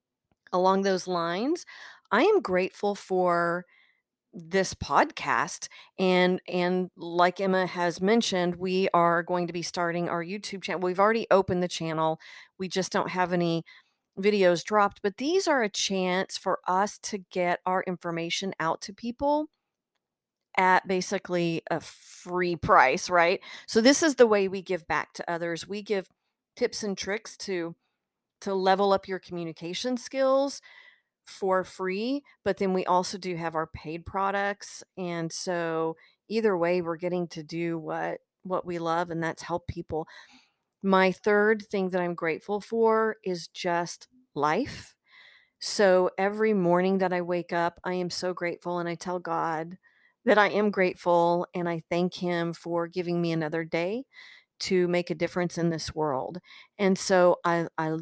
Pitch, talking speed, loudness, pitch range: 180 Hz, 160 wpm, -27 LUFS, 170-200 Hz